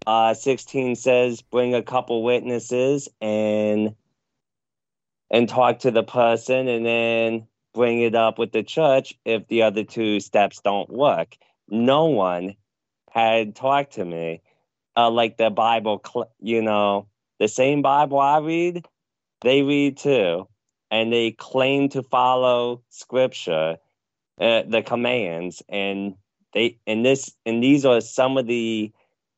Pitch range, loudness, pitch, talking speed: 110-130 Hz, -21 LUFS, 115 Hz, 135 wpm